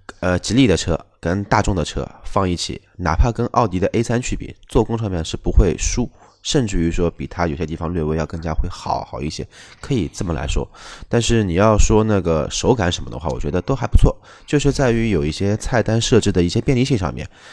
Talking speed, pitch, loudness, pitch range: 325 characters per minute, 100 Hz, -19 LUFS, 85-115 Hz